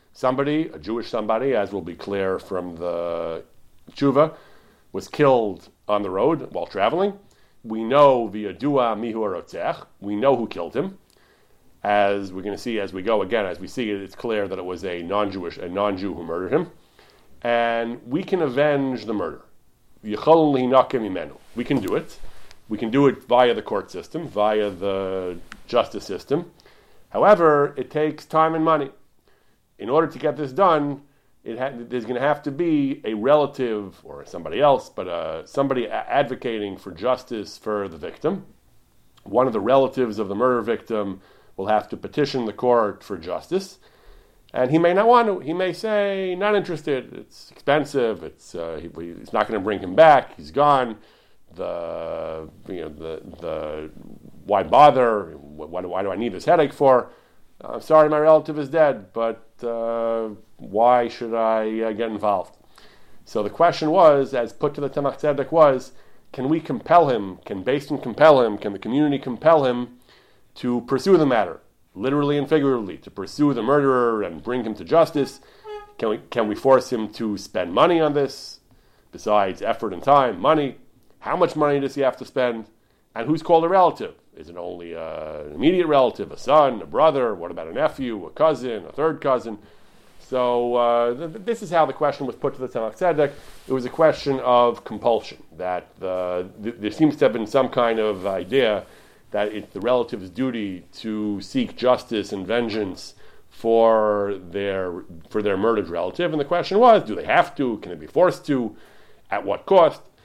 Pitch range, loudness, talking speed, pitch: 105-150 Hz, -21 LUFS, 180 wpm, 125 Hz